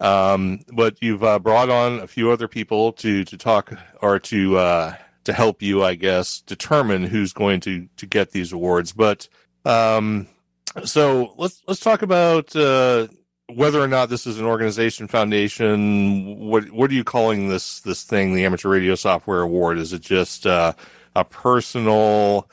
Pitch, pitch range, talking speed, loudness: 105 Hz, 95-115 Hz, 170 wpm, -19 LUFS